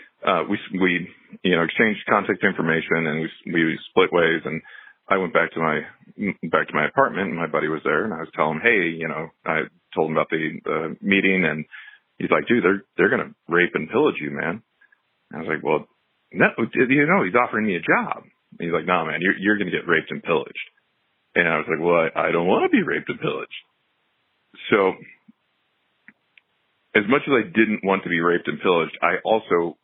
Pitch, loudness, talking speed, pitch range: 85 Hz, -21 LUFS, 225 wpm, 80-95 Hz